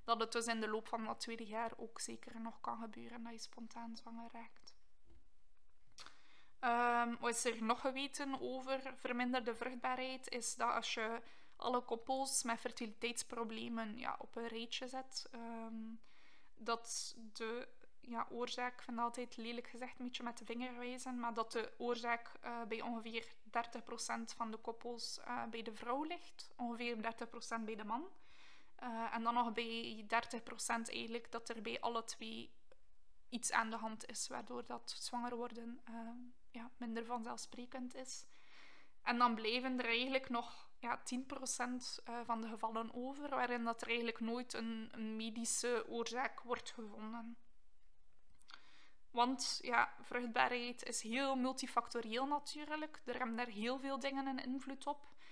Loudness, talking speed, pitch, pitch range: -42 LUFS, 155 wpm, 235 Hz, 230-250 Hz